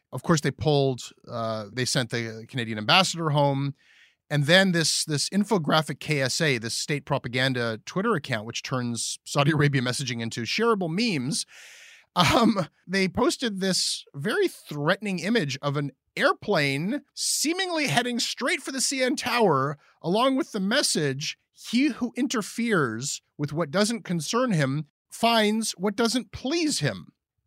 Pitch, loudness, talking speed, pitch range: 170 Hz, -25 LUFS, 140 wpm, 140-230 Hz